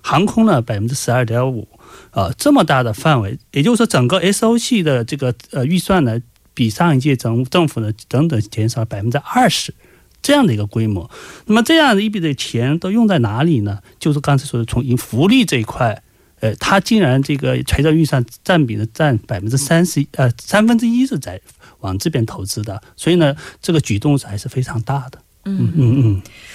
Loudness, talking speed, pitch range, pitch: -16 LUFS, 310 characters per minute, 115-175 Hz, 135 Hz